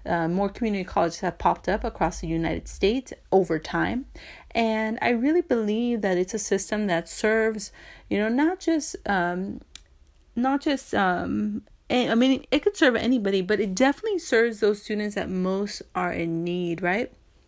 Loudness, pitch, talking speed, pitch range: -25 LUFS, 215 Hz, 170 wpm, 185-250 Hz